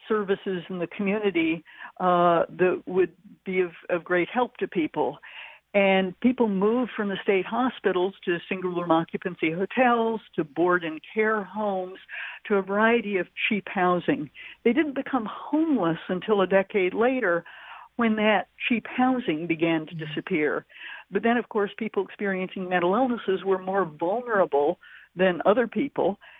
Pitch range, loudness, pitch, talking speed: 180-225 Hz, -25 LUFS, 195 Hz, 150 wpm